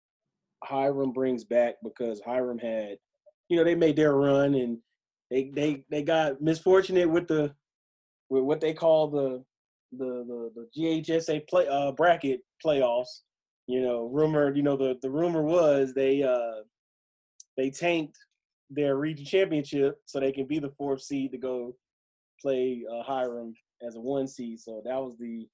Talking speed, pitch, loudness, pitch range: 160 wpm, 135 Hz, -27 LUFS, 125-155 Hz